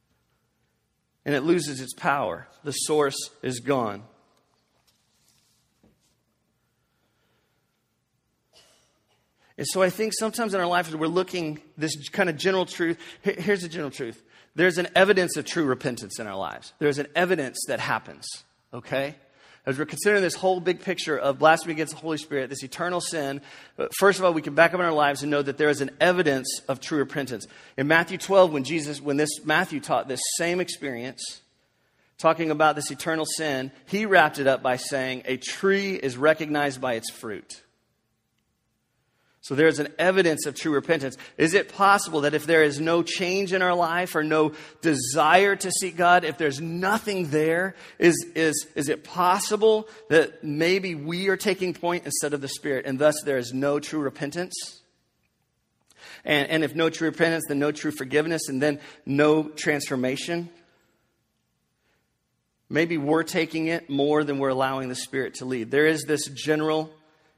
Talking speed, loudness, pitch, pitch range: 170 wpm, -24 LUFS, 155 Hz, 140-170 Hz